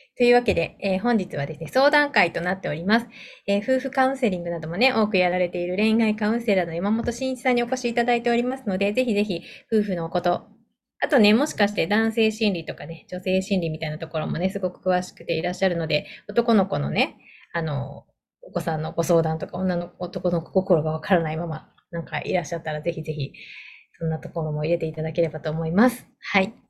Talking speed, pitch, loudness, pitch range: 450 characters per minute, 185 Hz, -23 LUFS, 165-225 Hz